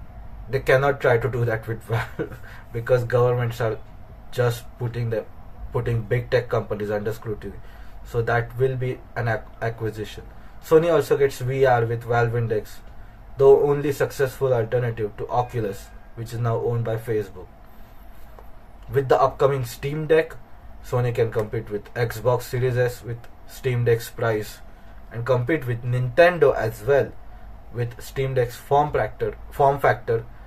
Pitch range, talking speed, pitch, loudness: 110-125 Hz, 145 wpm, 120 Hz, -23 LUFS